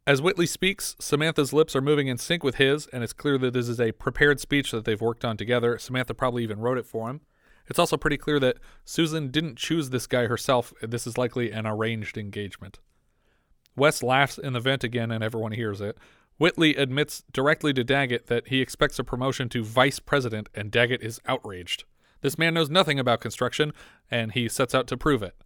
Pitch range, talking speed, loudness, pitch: 115-145 Hz, 210 wpm, -25 LUFS, 130 Hz